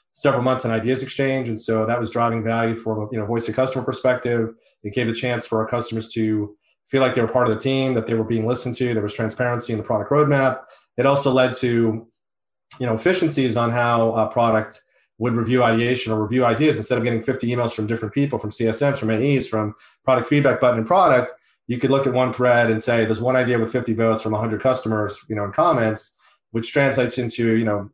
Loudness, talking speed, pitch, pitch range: -21 LUFS, 230 wpm, 120 Hz, 110-130 Hz